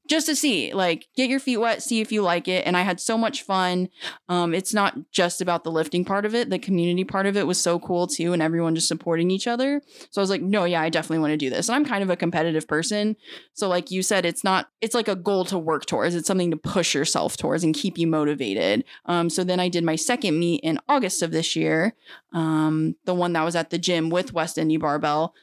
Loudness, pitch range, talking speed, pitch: -23 LUFS, 165-200 Hz, 260 wpm, 175 Hz